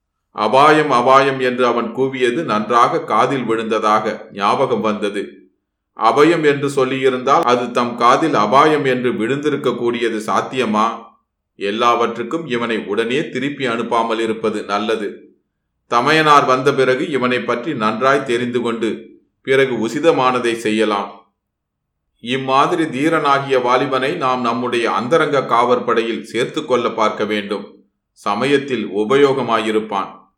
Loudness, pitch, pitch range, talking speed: -16 LUFS, 125 Hz, 110-135 Hz, 105 wpm